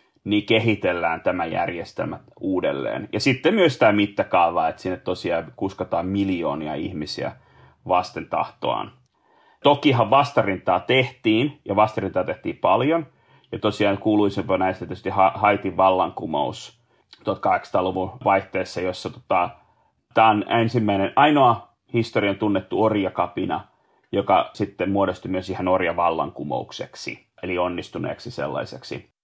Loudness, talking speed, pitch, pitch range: -22 LUFS, 105 wpm, 105 Hz, 95-115 Hz